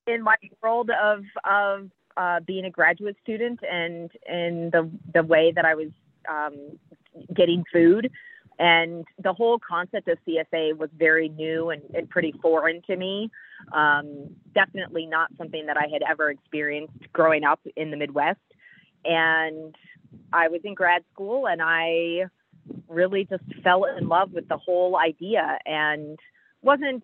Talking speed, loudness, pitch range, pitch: 155 wpm, -24 LUFS, 160-185 Hz, 170 Hz